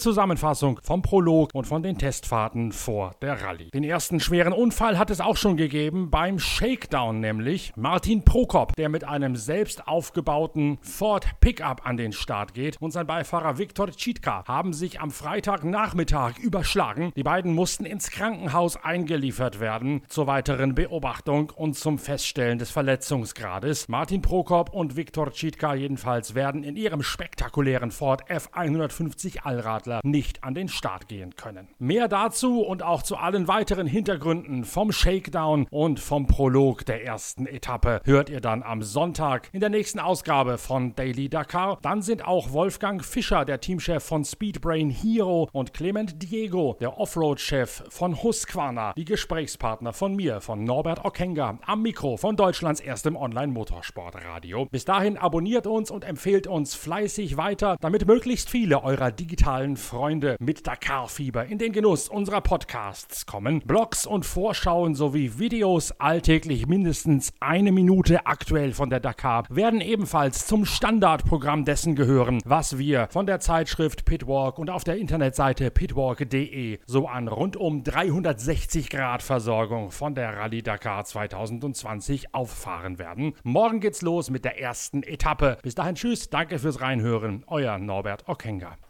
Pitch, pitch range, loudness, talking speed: 150 Hz, 130-180 Hz, -25 LUFS, 150 wpm